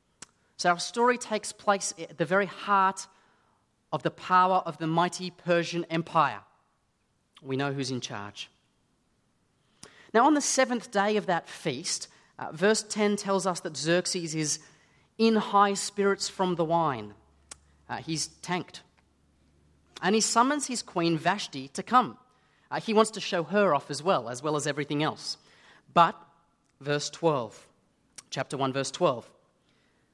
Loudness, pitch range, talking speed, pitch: -27 LUFS, 150-200 Hz, 150 wpm, 175 Hz